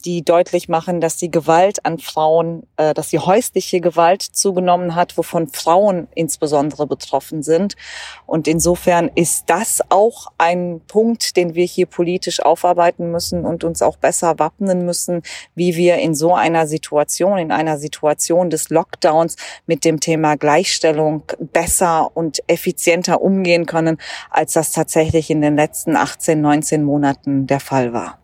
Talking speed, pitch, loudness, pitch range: 150 wpm, 165 Hz, -16 LUFS, 155-175 Hz